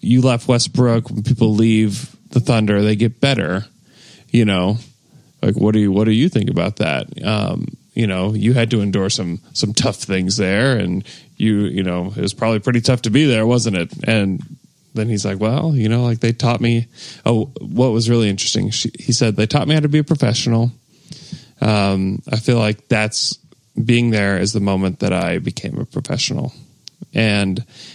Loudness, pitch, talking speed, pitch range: -17 LUFS, 115 Hz, 200 wpm, 105-125 Hz